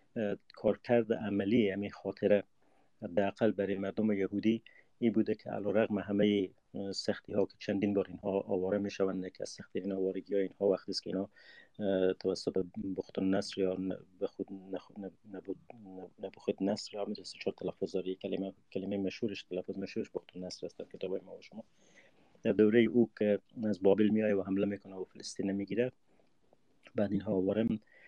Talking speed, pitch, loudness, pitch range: 160 wpm, 100 Hz, -34 LUFS, 95-105 Hz